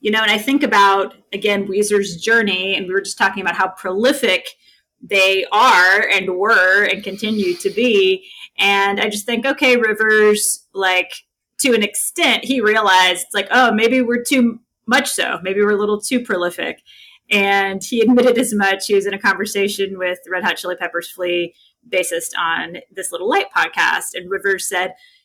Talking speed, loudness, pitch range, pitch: 180 wpm, -16 LUFS, 190-235 Hz, 205 Hz